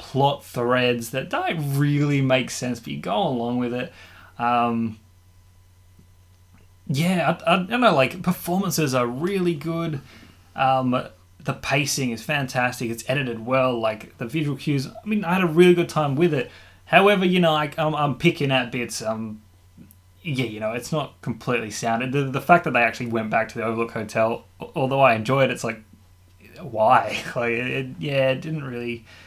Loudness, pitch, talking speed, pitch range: -22 LUFS, 125 Hz, 185 wpm, 110-145 Hz